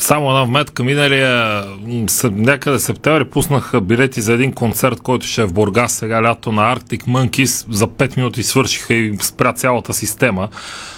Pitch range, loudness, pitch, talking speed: 115-130 Hz, -15 LUFS, 120 Hz, 165 wpm